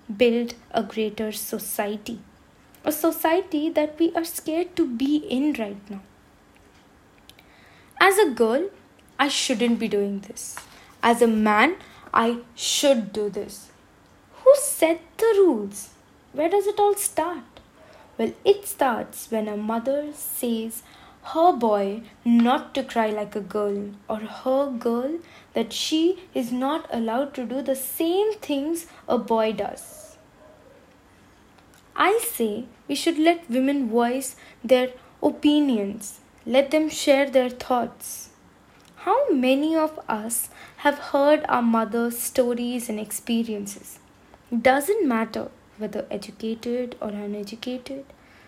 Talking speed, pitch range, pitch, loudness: 125 wpm, 225-305 Hz, 255 Hz, -23 LUFS